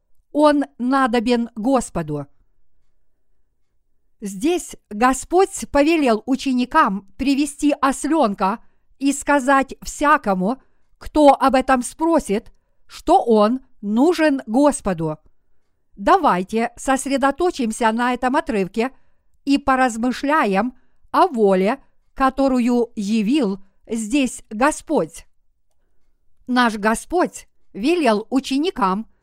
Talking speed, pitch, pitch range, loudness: 75 wpm, 255 Hz, 210-280 Hz, -19 LUFS